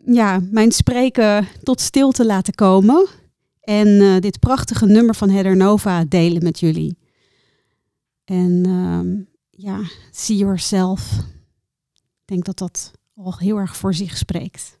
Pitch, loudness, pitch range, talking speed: 190 Hz, -16 LUFS, 170-210 Hz, 135 wpm